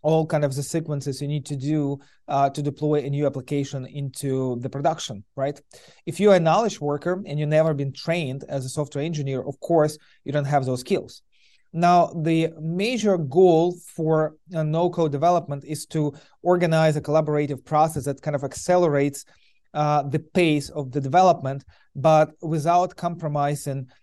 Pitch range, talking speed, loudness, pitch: 140-165 Hz, 165 wpm, -23 LUFS, 150 Hz